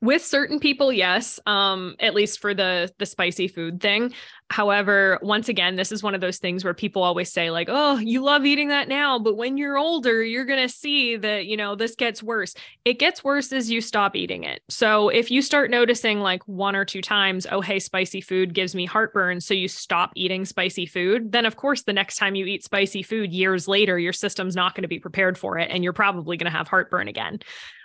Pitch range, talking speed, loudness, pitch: 185-240 Hz, 225 wpm, -22 LUFS, 205 Hz